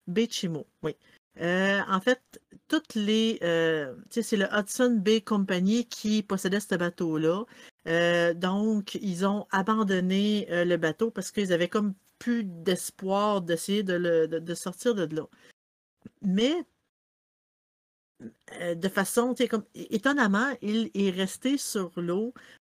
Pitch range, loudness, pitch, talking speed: 175-225 Hz, -28 LUFS, 195 Hz, 130 wpm